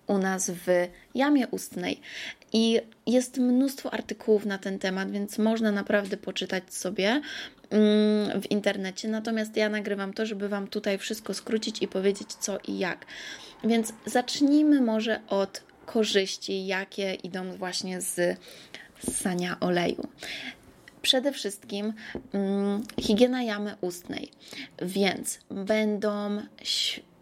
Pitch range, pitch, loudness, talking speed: 195-230 Hz, 210 Hz, -28 LUFS, 115 wpm